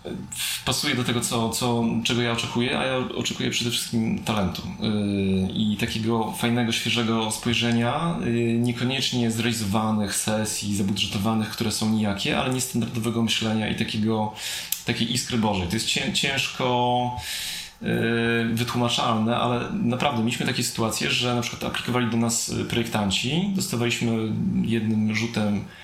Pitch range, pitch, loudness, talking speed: 110-120 Hz, 115 Hz, -24 LUFS, 130 wpm